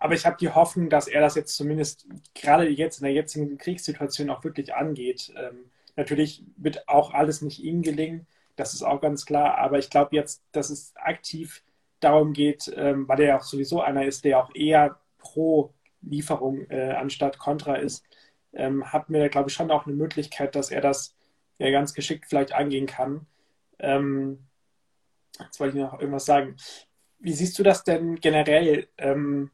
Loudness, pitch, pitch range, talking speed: -24 LUFS, 145 Hz, 140-155 Hz, 185 wpm